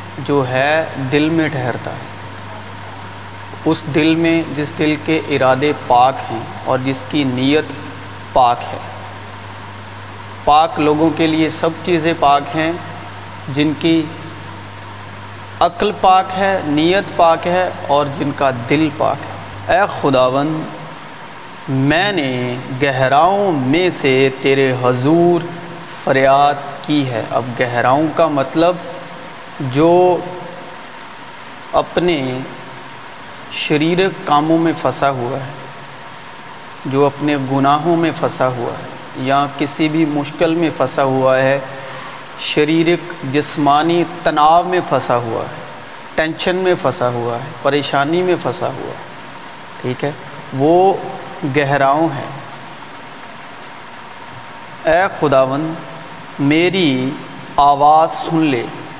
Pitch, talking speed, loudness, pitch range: 145 Hz, 110 wpm, -15 LUFS, 130-160 Hz